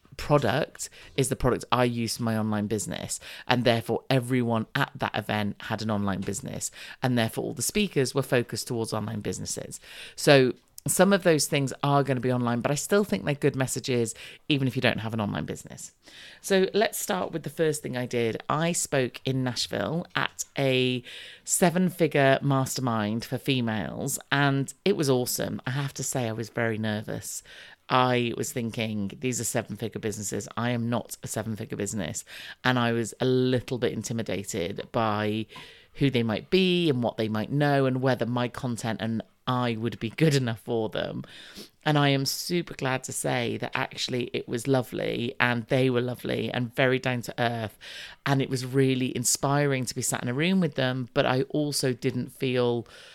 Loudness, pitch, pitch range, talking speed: -27 LUFS, 125 Hz, 115-135 Hz, 190 wpm